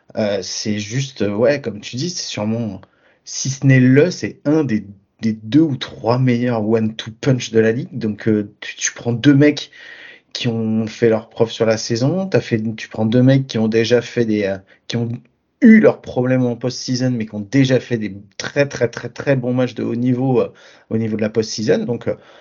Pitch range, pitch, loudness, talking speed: 110-130 Hz, 120 Hz, -18 LUFS, 225 wpm